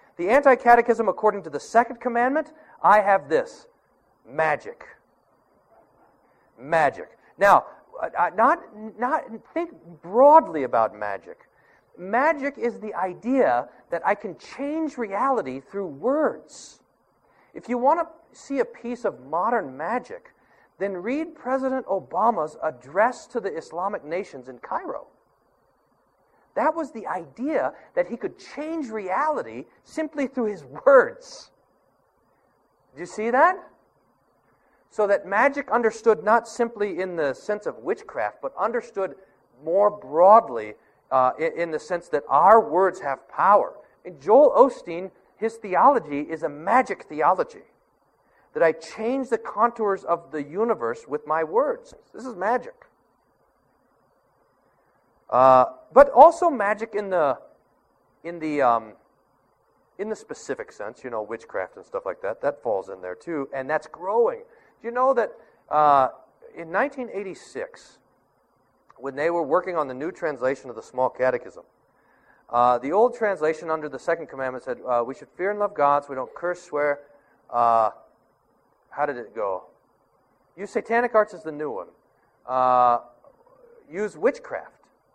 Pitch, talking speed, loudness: 215 Hz, 140 wpm, -23 LUFS